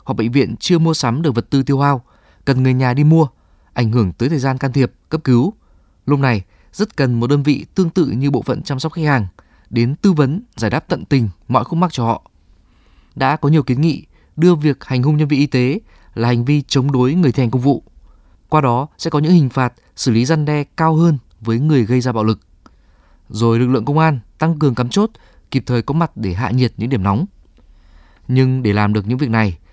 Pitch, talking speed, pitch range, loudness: 130 Hz, 245 wpm, 115-150 Hz, -16 LUFS